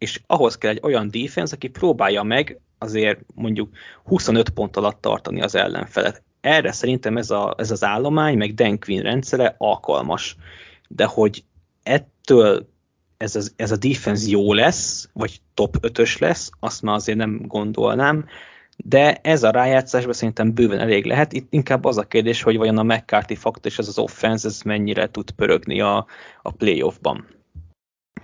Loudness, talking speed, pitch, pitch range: -20 LUFS, 165 wpm, 110 Hz, 105-125 Hz